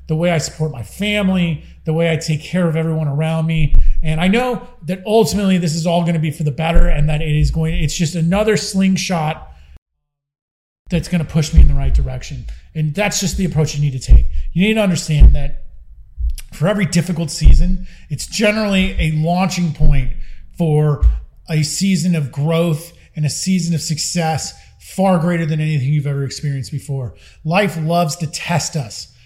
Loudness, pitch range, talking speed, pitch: -17 LUFS, 145-175 Hz, 190 wpm, 160 Hz